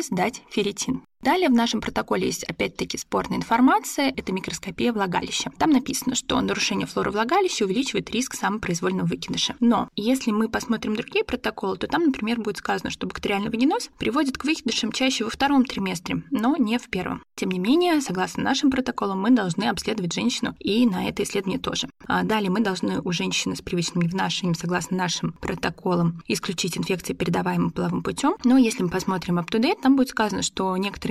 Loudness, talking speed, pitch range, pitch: -24 LUFS, 175 wpm, 190-255 Hz, 220 Hz